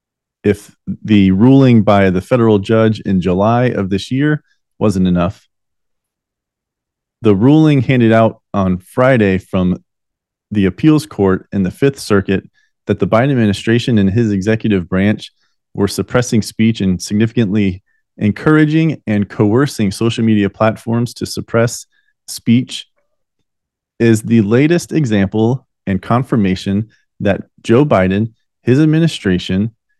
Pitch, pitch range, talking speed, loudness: 110 Hz, 100-125 Hz, 120 wpm, -14 LUFS